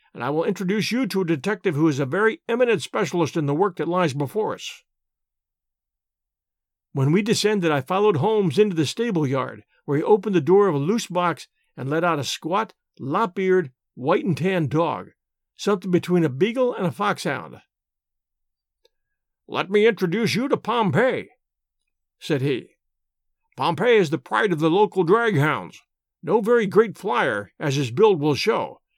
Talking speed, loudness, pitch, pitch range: 165 wpm, -22 LUFS, 180 Hz, 150-210 Hz